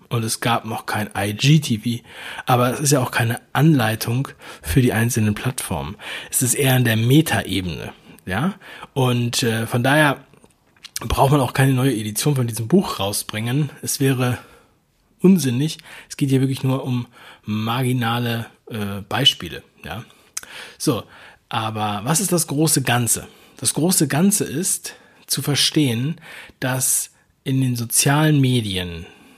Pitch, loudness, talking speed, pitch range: 130 Hz, -19 LUFS, 140 wpm, 115-145 Hz